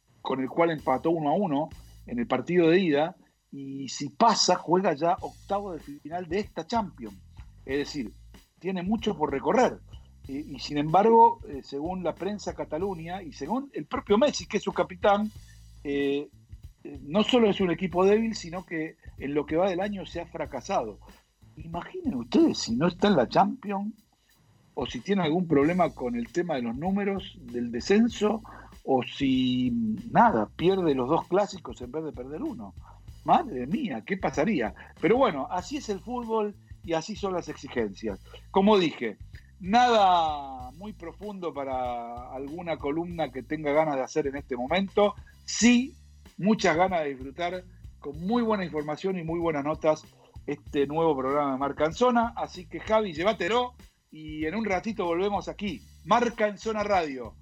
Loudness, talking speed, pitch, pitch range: -27 LUFS, 170 wpm, 170 Hz, 140-205 Hz